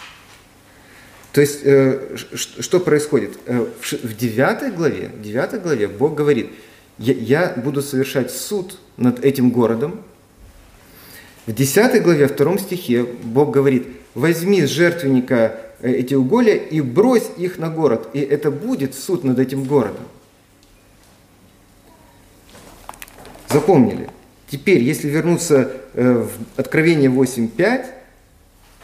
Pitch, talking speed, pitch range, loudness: 130 Hz, 100 wpm, 110-150 Hz, -18 LUFS